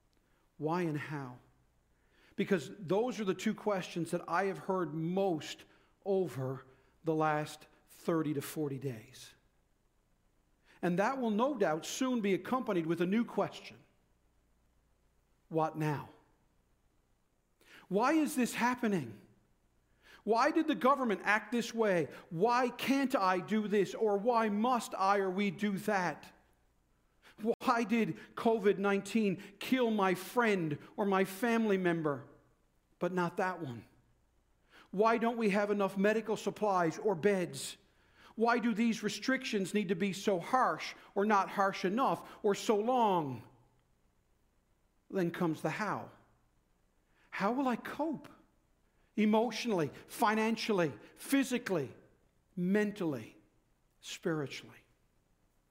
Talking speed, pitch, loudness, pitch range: 120 wpm, 195 Hz, -33 LUFS, 155-220 Hz